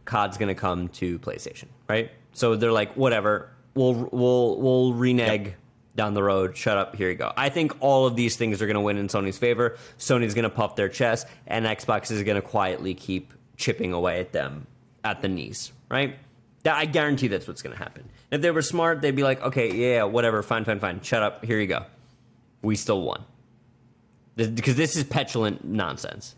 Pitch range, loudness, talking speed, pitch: 105-125 Hz, -25 LUFS, 195 wpm, 115 Hz